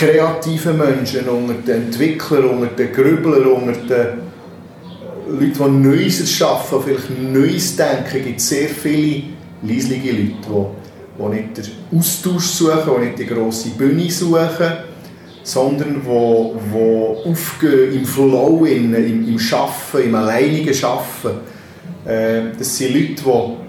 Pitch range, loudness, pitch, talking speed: 120-155 Hz, -16 LUFS, 135 Hz, 120 wpm